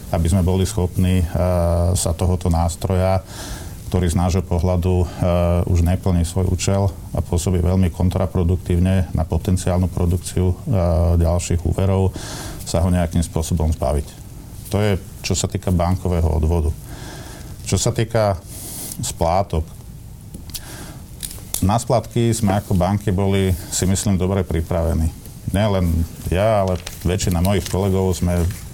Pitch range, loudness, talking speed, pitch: 85-100 Hz, -20 LUFS, 120 wpm, 90 Hz